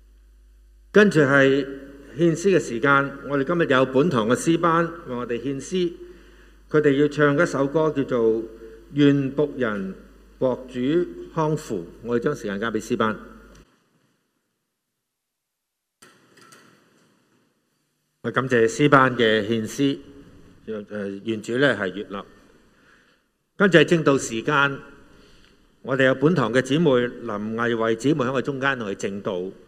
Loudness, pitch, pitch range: -21 LUFS, 135 Hz, 115-150 Hz